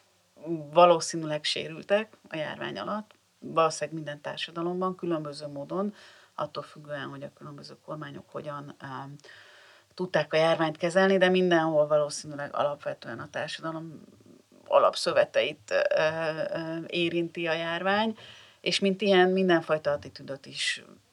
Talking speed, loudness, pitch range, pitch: 115 wpm, -27 LUFS, 150-185 Hz, 165 Hz